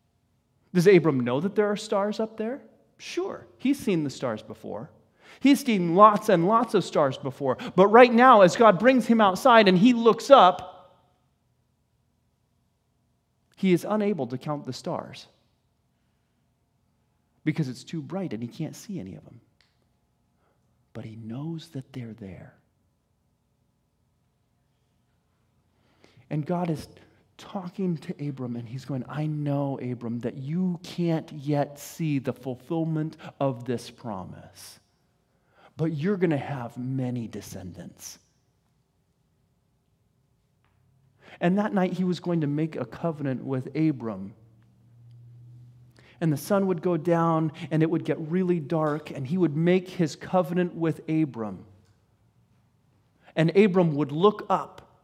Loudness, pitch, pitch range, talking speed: -24 LUFS, 150 Hz, 120-180 Hz, 135 wpm